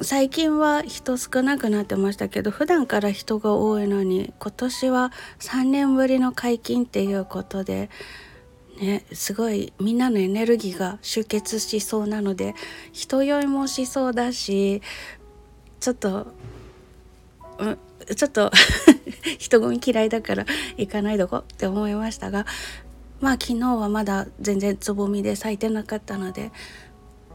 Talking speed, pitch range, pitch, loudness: 270 characters per minute, 200-255 Hz, 220 Hz, -23 LUFS